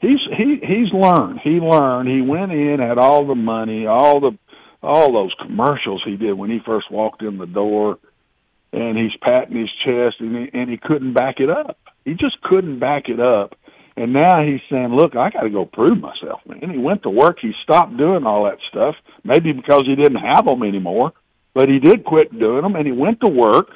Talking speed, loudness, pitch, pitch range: 215 wpm, -16 LUFS, 135 Hz, 115-155 Hz